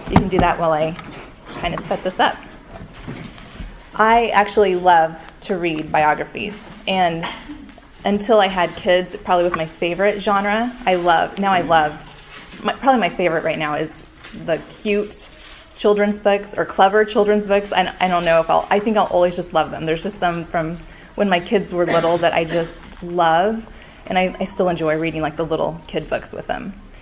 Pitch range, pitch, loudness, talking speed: 165-205 Hz, 180 Hz, -19 LUFS, 195 wpm